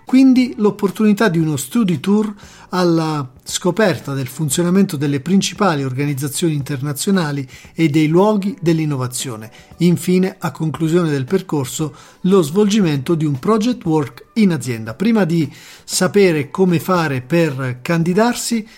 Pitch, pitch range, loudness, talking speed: 170 Hz, 145-195 Hz, -17 LUFS, 120 wpm